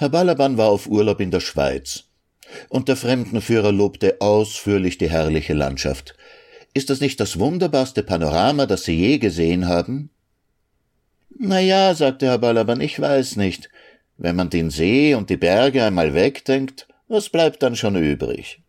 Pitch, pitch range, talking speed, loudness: 115 Hz, 90-135 Hz, 155 wpm, -19 LUFS